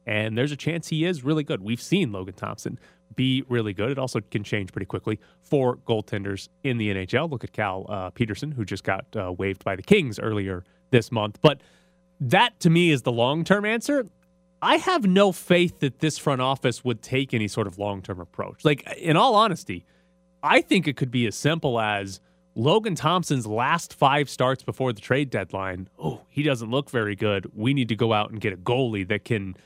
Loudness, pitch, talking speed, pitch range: -24 LUFS, 125 Hz, 210 wpm, 105-155 Hz